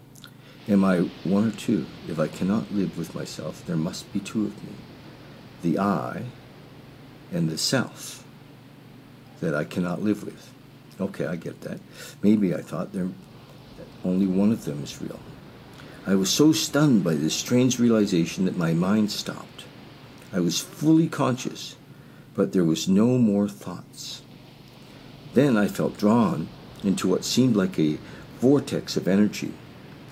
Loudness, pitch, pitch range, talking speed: -24 LUFS, 110 Hz, 95-140 Hz, 150 wpm